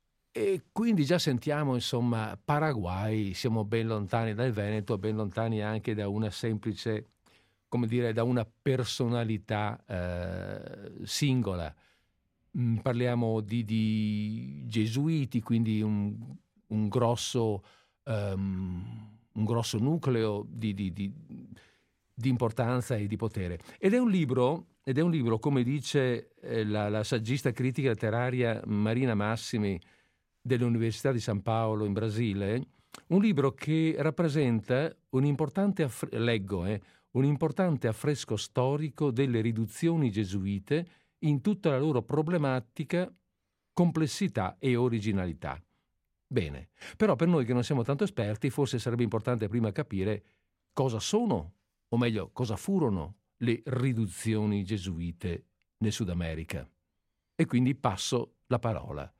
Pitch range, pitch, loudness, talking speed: 105-135 Hz, 115 Hz, -30 LUFS, 125 wpm